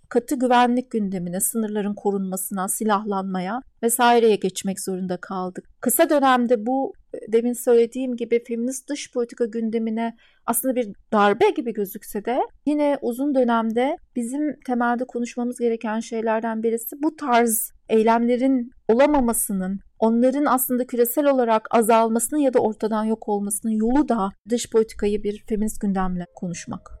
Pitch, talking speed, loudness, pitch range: 230 Hz, 125 wpm, -22 LUFS, 215-250 Hz